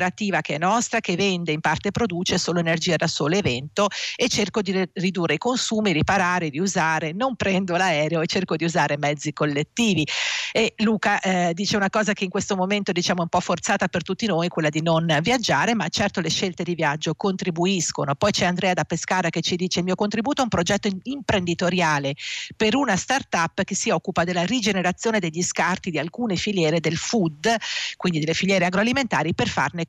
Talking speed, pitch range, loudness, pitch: 190 wpm, 165-205 Hz, -22 LUFS, 185 Hz